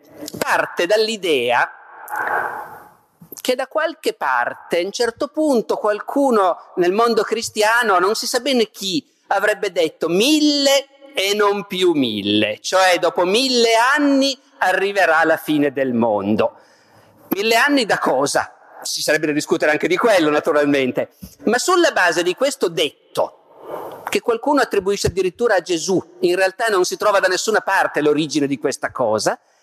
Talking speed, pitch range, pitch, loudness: 145 wpm, 175-280 Hz, 220 Hz, -18 LUFS